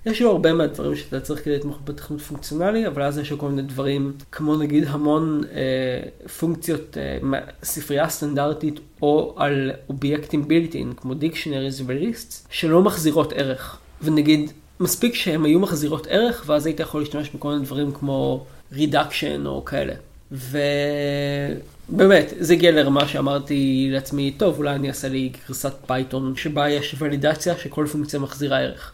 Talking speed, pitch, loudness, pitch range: 150 wpm, 145 Hz, -22 LUFS, 140-155 Hz